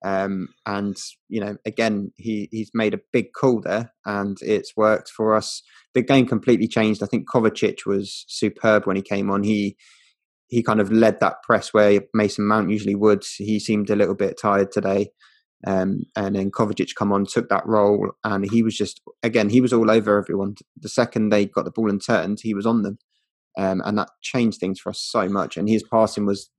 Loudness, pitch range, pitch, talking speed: -21 LUFS, 100-110 Hz, 105 Hz, 210 wpm